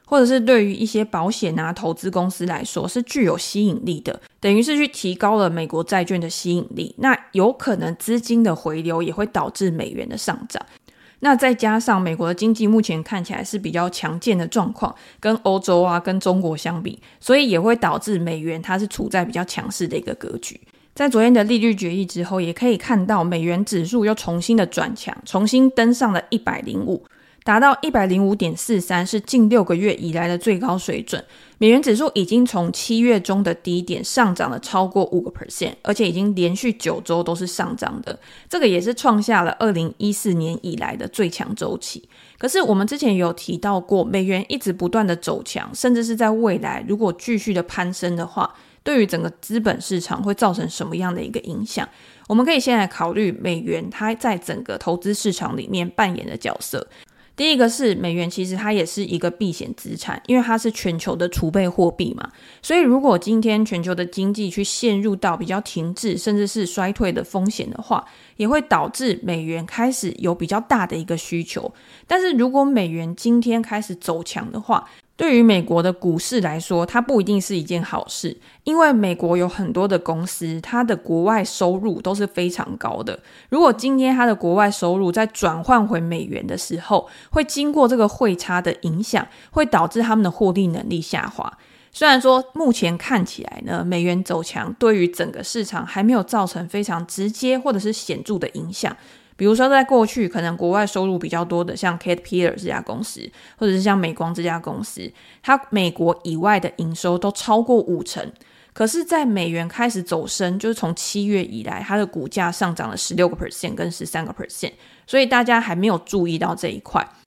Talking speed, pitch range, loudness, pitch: 315 characters per minute, 175-230 Hz, -20 LUFS, 200 Hz